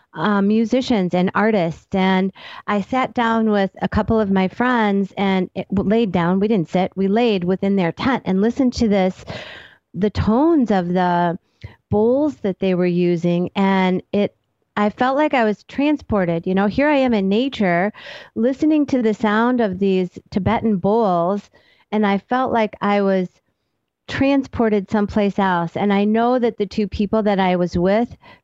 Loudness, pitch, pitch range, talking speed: -19 LUFS, 205 Hz, 190-230 Hz, 175 wpm